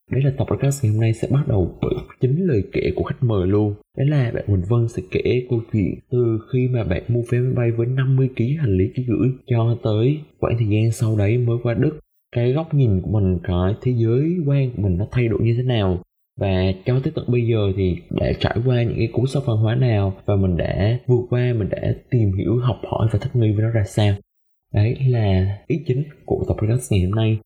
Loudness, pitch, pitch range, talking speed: -20 LUFS, 115 Hz, 100-125 Hz, 245 wpm